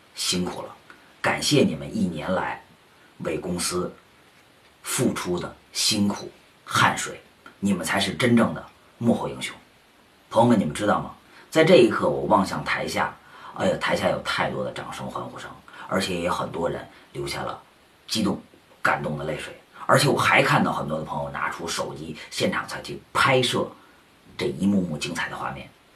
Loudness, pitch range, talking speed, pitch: -24 LUFS, 90-100 Hz, 250 characters per minute, 95 Hz